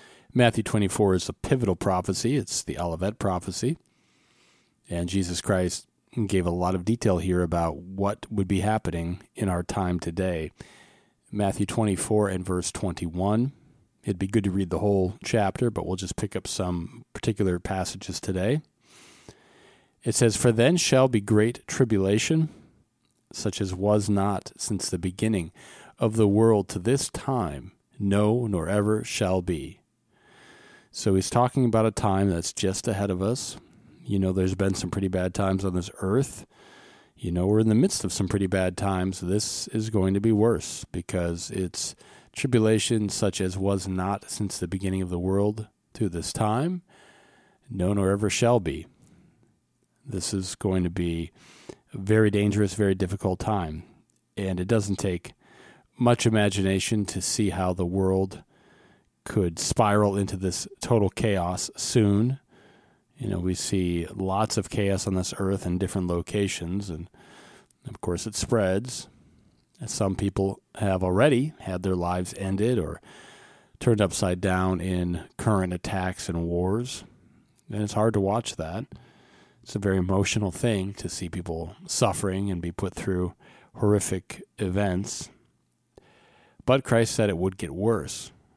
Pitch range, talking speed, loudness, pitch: 90-110 Hz, 155 wpm, -26 LUFS, 100 Hz